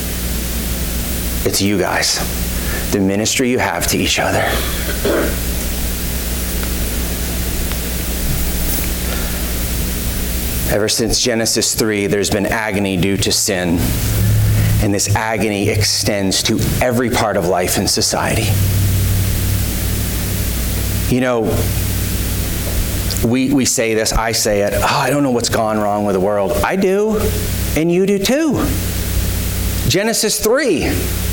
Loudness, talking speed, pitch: -16 LUFS, 110 wpm, 95 Hz